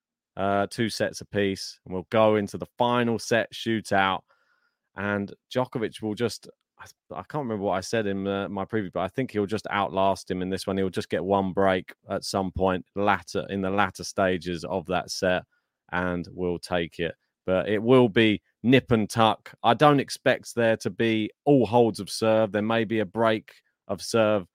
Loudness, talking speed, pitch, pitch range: -25 LUFS, 200 wpm, 100 Hz, 95-115 Hz